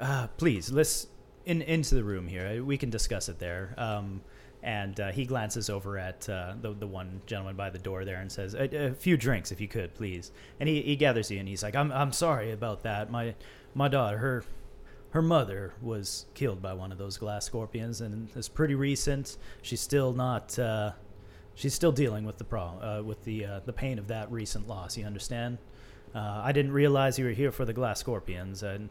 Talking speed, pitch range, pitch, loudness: 215 wpm, 100-135 Hz, 110 Hz, -32 LUFS